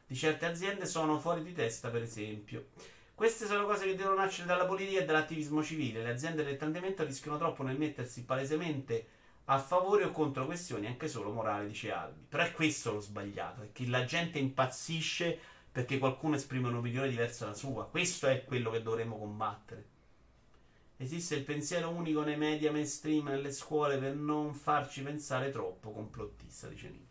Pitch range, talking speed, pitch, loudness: 125-160 Hz, 175 wpm, 145 Hz, -35 LUFS